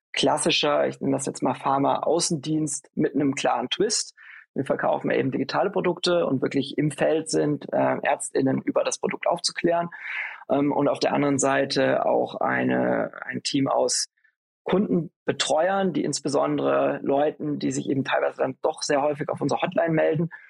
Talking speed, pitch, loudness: 160 wpm, 145 Hz, -24 LUFS